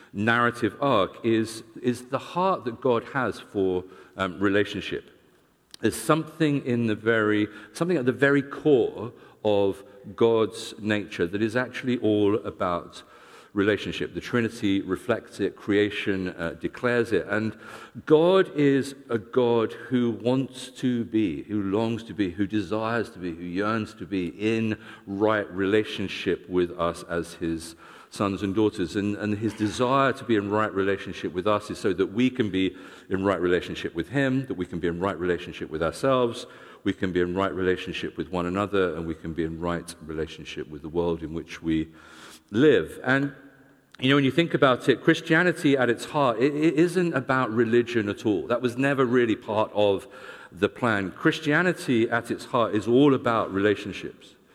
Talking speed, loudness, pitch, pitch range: 175 wpm, -25 LUFS, 110 Hz, 95-125 Hz